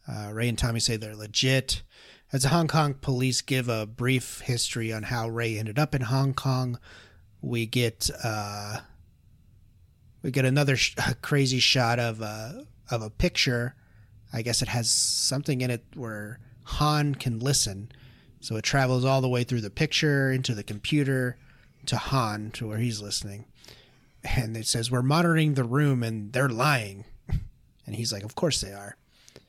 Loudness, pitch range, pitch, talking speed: -26 LUFS, 110-130 Hz, 120 Hz, 170 wpm